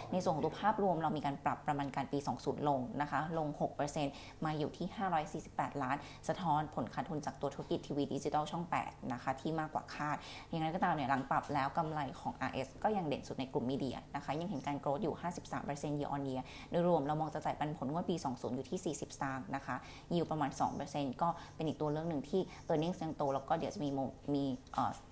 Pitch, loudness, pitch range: 150 Hz, -38 LUFS, 140-160 Hz